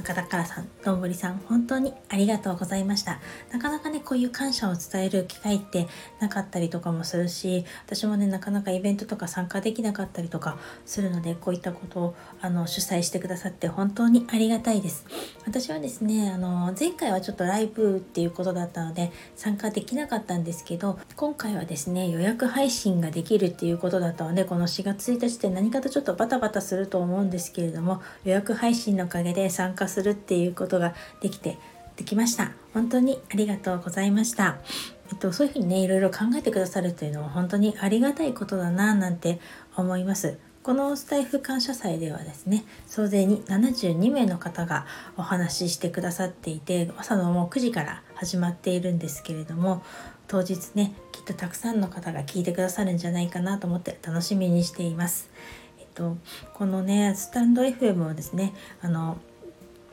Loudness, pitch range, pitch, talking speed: -27 LUFS, 175-215 Hz, 190 Hz, 410 characters per minute